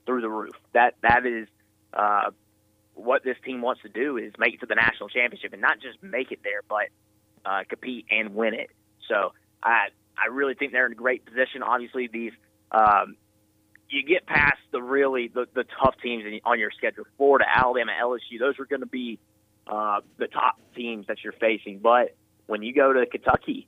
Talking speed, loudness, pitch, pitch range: 200 wpm, -25 LUFS, 120 Hz, 105-130 Hz